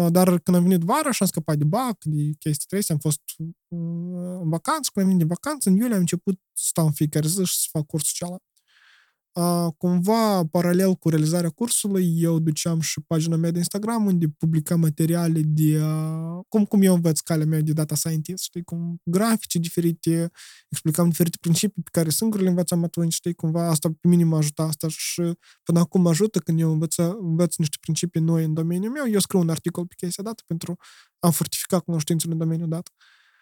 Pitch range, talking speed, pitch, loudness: 160-185 Hz, 200 wpm, 170 Hz, -23 LUFS